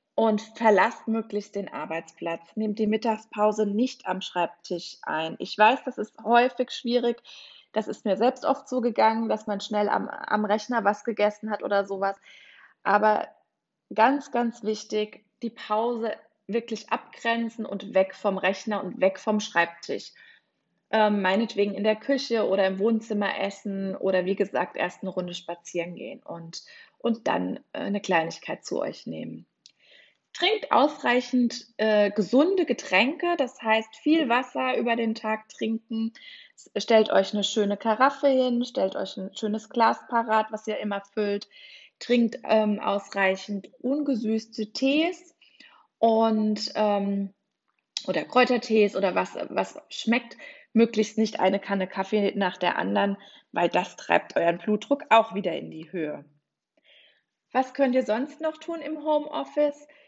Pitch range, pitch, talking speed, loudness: 200-245 Hz, 220 Hz, 145 wpm, -26 LUFS